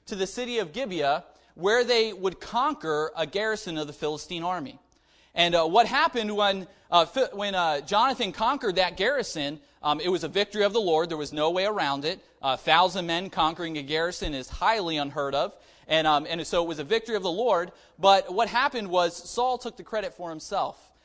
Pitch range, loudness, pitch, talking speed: 160-210 Hz, -26 LUFS, 180 Hz, 205 wpm